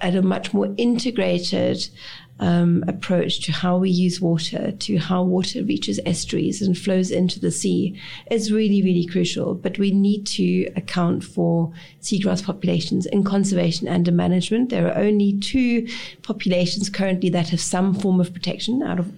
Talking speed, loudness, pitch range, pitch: 165 wpm, -21 LUFS, 175-200 Hz, 185 Hz